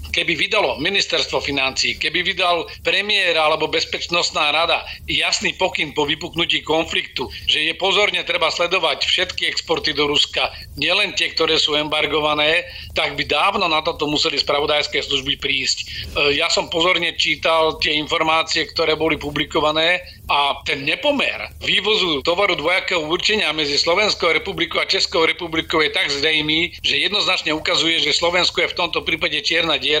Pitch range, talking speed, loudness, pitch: 150-175 Hz, 150 wpm, -17 LUFS, 160 Hz